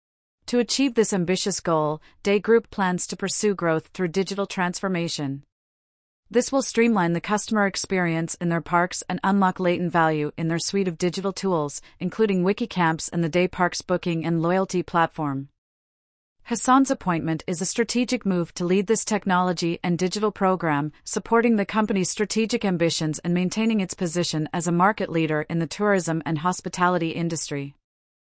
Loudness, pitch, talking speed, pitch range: -23 LUFS, 180 Hz, 160 wpm, 165-200 Hz